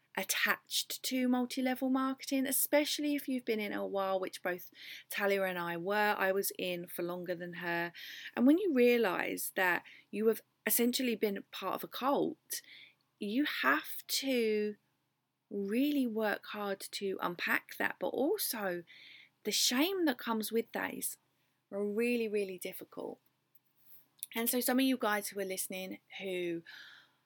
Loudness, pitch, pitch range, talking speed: -34 LUFS, 215 Hz, 190-255 Hz, 150 wpm